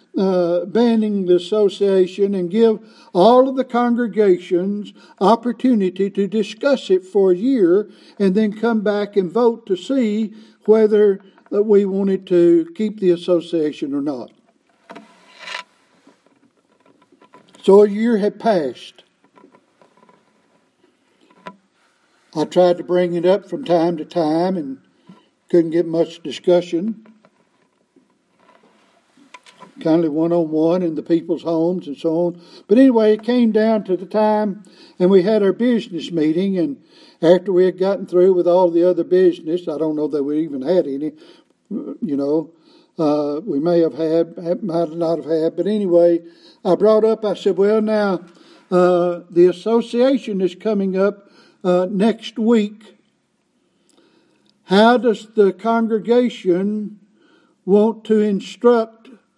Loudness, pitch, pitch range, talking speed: -17 LUFS, 195 Hz, 175-220 Hz, 135 wpm